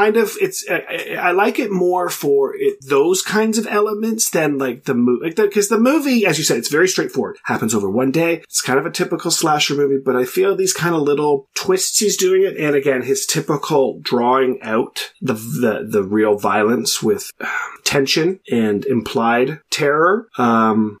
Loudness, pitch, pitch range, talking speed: -17 LUFS, 170 Hz, 135-215 Hz, 195 wpm